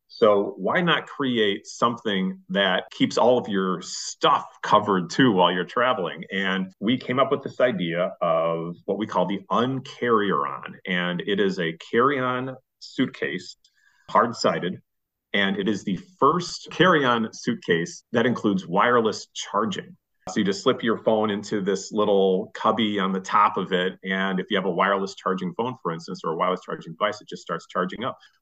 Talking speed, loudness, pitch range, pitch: 180 wpm, -24 LUFS, 95-120 Hz, 100 Hz